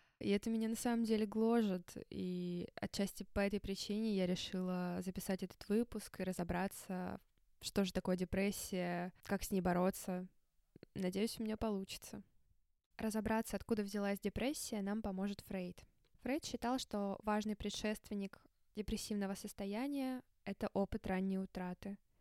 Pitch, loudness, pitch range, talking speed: 200 Hz, -41 LUFS, 190-220 Hz, 130 wpm